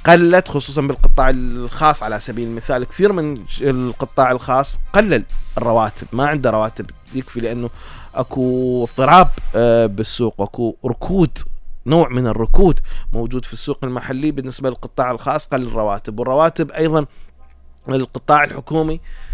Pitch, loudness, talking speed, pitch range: 130 Hz, -17 LUFS, 120 wpm, 115-145 Hz